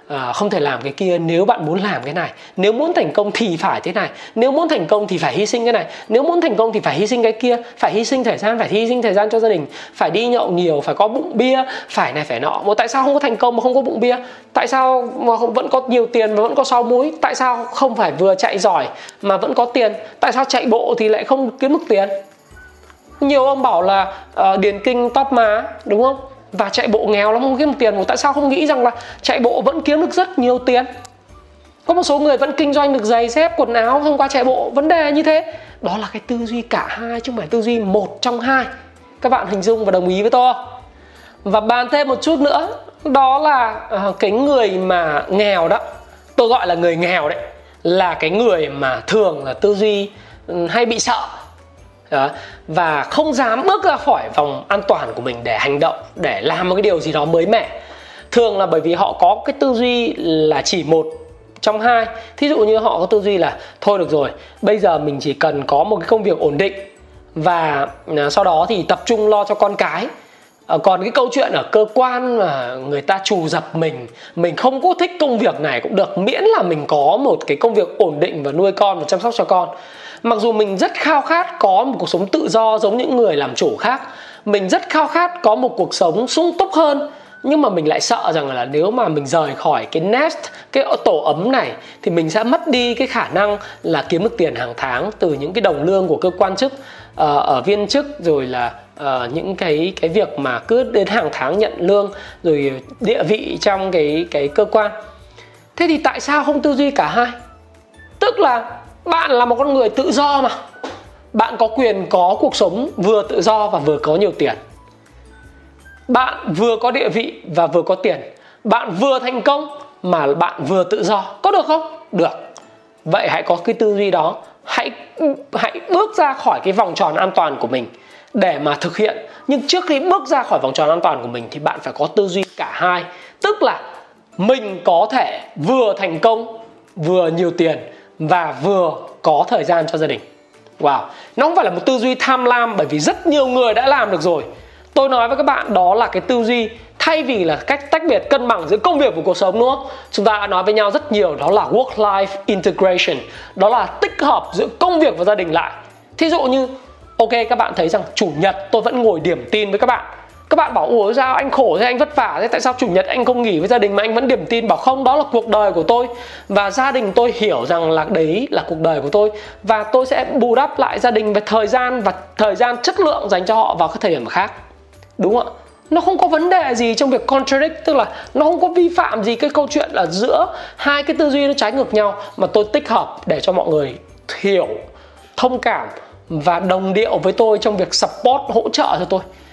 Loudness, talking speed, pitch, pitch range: -16 LUFS, 240 wpm, 230 Hz, 195-265 Hz